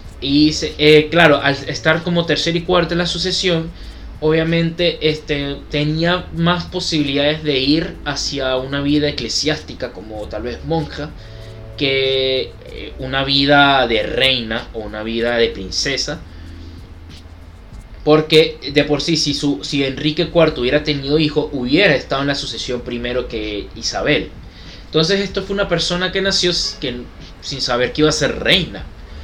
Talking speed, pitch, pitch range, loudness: 150 wpm, 140 Hz, 115-155 Hz, -16 LUFS